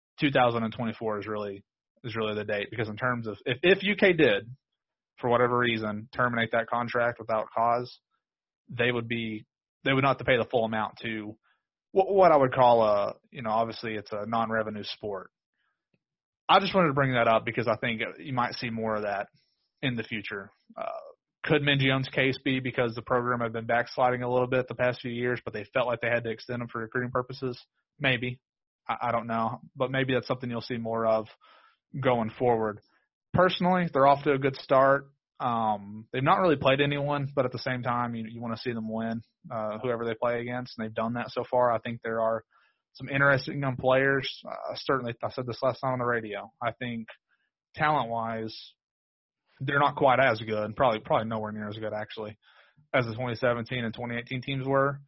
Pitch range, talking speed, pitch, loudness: 110-130 Hz, 210 wpm, 120 Hz, -28 LUFS